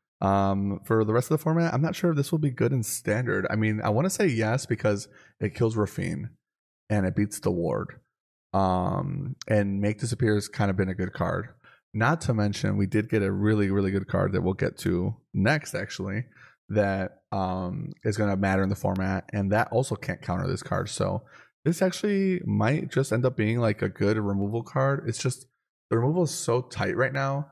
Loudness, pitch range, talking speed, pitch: -27 LUFS, 100-135 Hz, 215 wpm, 110 Hz